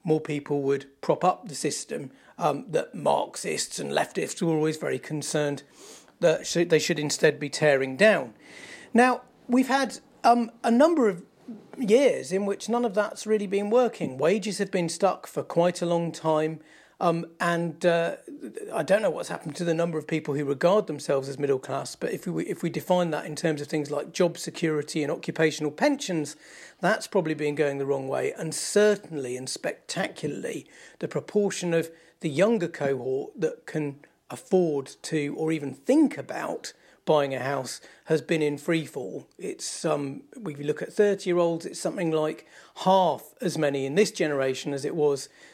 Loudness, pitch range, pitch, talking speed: -26 LUFS, 150-200 Hz, 165 Hz, 180 wpm